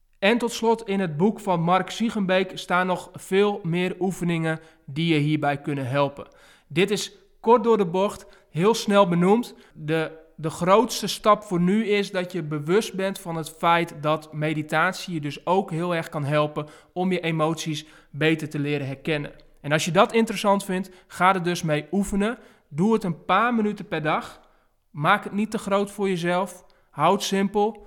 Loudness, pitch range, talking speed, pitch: -24 LUFS, 160-200 Hz, 185 wpm, 185 Hz